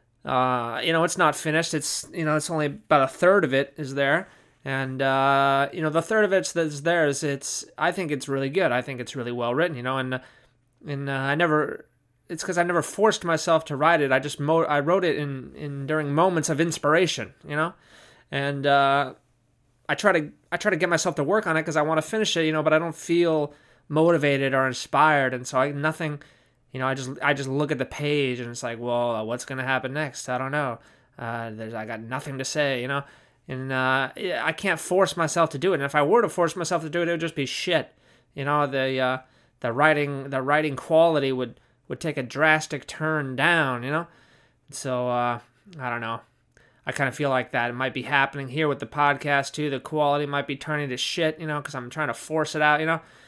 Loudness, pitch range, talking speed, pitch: -24 LUFS, 130-160 Hz, 240 wpm, 145 Hz